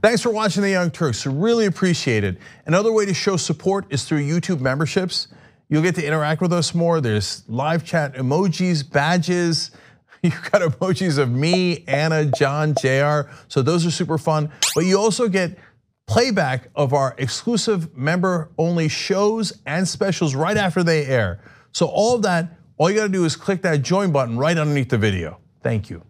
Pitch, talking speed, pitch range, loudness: 165 Hz, 180 wpm, 140-185 Hz, -20 LUFS